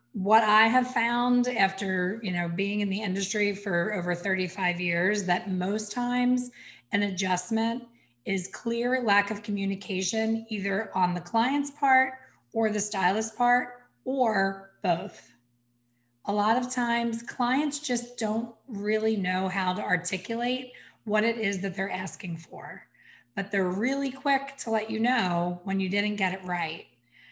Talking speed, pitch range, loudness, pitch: 150 wpm, 185-235 Hz, -27 LUFS, 205 Hz